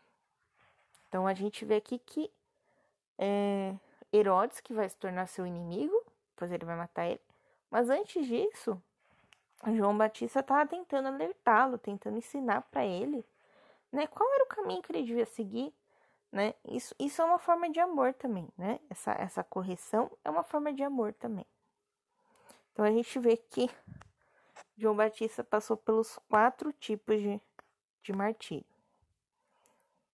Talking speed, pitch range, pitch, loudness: 145 wpm, 205-295 Hz, 230 Hz, -33 LUFS